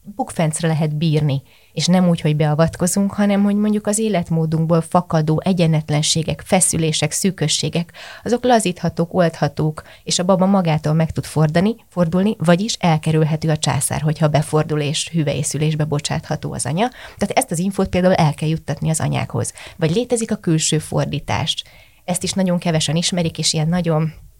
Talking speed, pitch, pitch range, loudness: 155 wpm, 160 Hz, 155-180 Hz, -18 LUFS